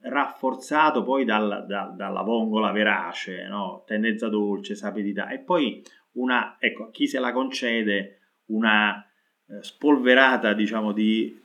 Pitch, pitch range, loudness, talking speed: 110 Hz, 105-125 Hz, -24 LUFS, 120 wpm